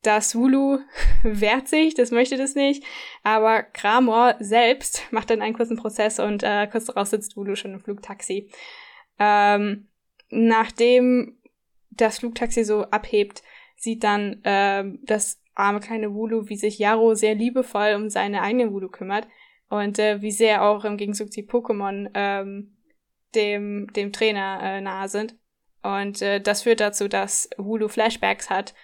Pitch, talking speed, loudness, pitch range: 215 Hz, 150 wpm, -22 LUFS, 205-235 Hz